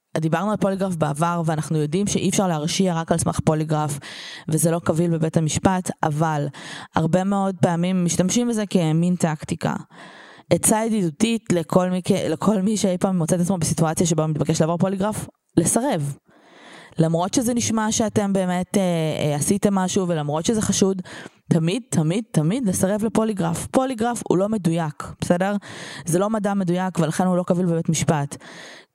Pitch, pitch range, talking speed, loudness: 180 Hz, 165-195 Hz, 160 wpm, -21 LUFS